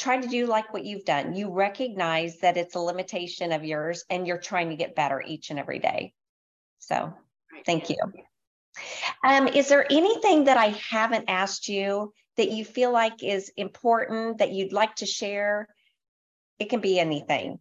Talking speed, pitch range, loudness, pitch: 175 wpm, 180-230 Hz, -26 LUFS, 205 Hz